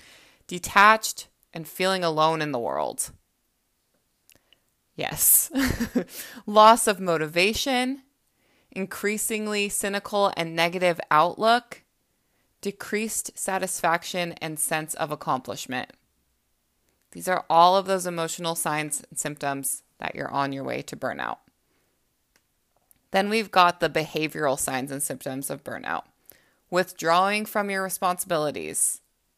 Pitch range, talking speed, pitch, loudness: 155-205 Hz, 105 wpm, 175 Hz, -24 LUFS